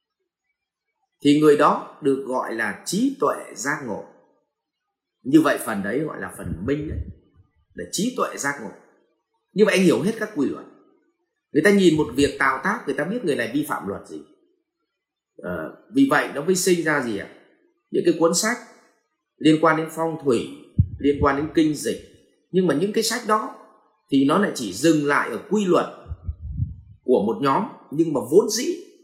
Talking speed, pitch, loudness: 195 wpm, 205 Hz, -22 LUFS